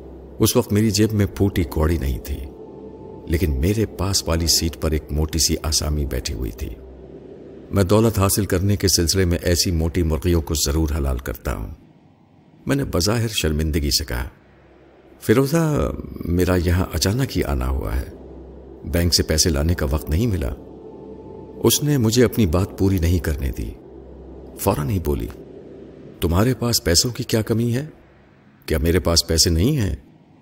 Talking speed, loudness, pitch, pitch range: 165 wpm, -20 LUFS, 85 Hz, 75-100 Hz